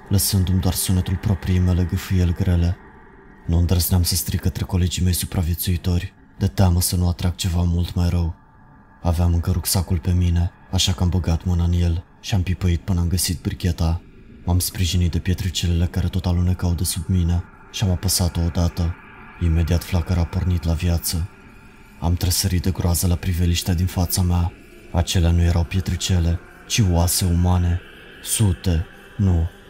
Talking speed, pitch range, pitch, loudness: 165 wpm, 85-95 Hz, 90 Hz, -21 LUFS